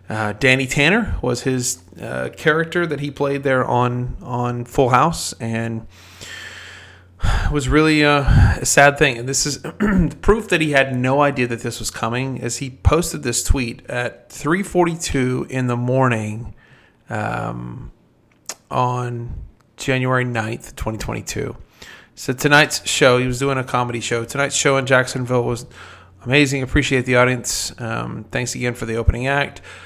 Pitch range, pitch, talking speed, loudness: 115-140 Hz, 125 Hz, 150 wpm, -19 LUFS